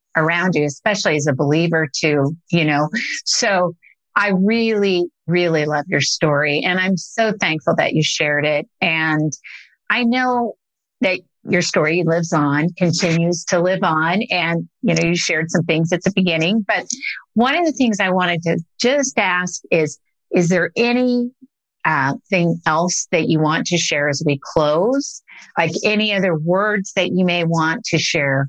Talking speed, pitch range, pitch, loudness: 170 wpm, 155-195 Hz, 175 Hz, -18 LUFS